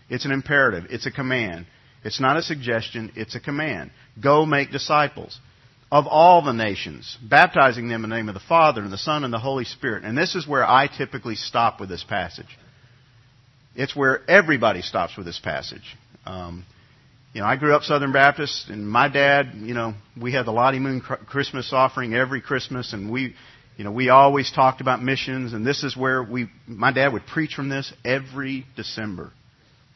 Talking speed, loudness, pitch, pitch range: 190 wpm, -21 LUFS, 130 Hz, 115-140 Hz